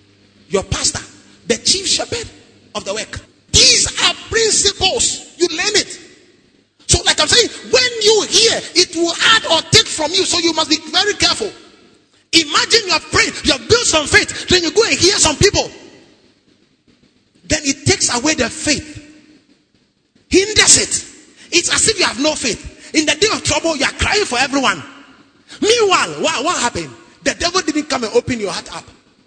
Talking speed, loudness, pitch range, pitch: 175 wpm, -13 LUFS, 305-410 Hz, 340 Hz